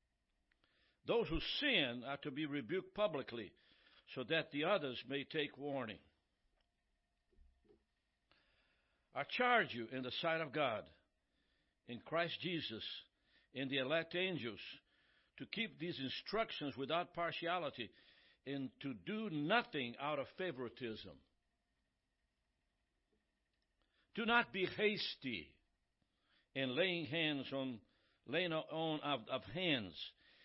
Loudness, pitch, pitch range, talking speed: -41 LUFS, 145 Hz, 120-175 Hz, 110 wpm